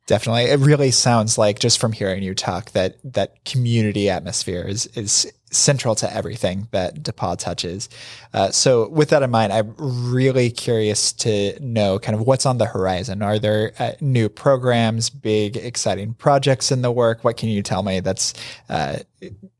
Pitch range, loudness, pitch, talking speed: 105-125 Hz, -19 LUFS, 115 Hz, 175 wpm